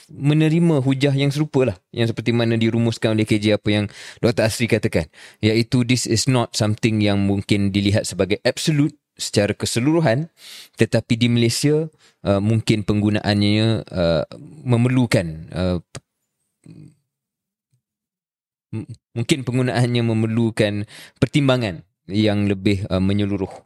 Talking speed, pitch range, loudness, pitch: 115 wpm, 105-140 Hz, -20 LUFS, 115 Hz